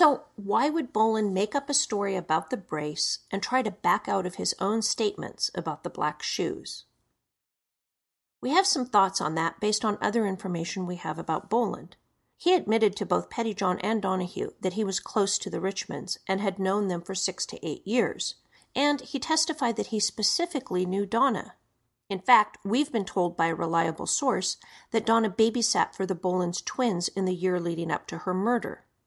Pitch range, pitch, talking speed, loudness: 185-230 Hz, 205 Hz, 195 wpm, -27 LUFS